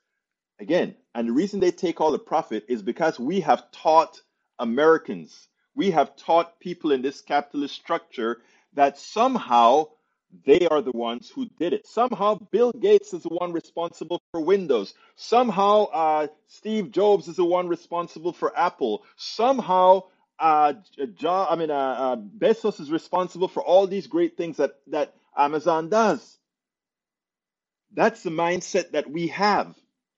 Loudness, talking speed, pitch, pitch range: -23 LUFS, 155 wpm, 175 Hz, 155-210 Hz